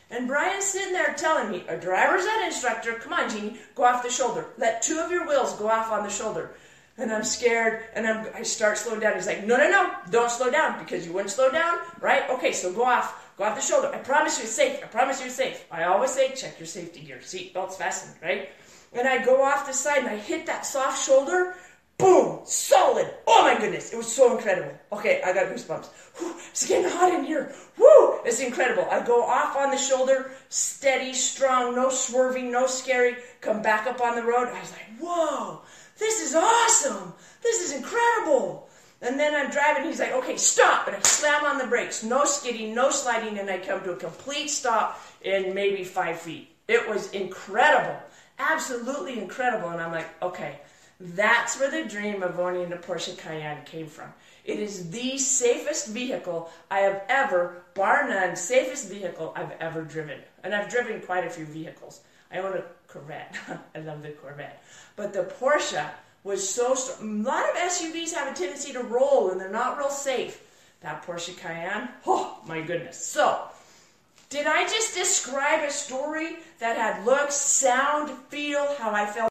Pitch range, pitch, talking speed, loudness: 190-285 Hz, 245 Hz, 195 wpm, -24 LUFS